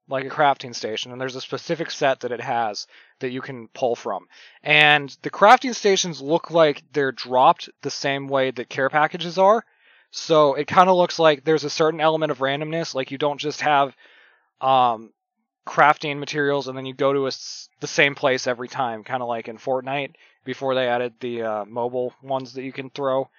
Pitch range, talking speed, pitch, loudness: 130-150 Hz, 205 wpm, 135 Hz, -21 LUFS